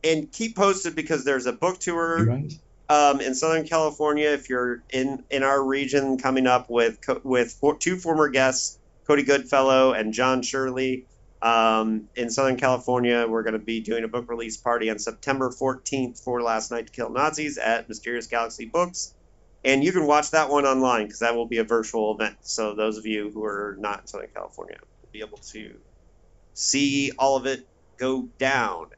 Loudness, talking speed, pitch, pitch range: -24 LUFS, 190 wpm, 130 Hz, 115-140 Hz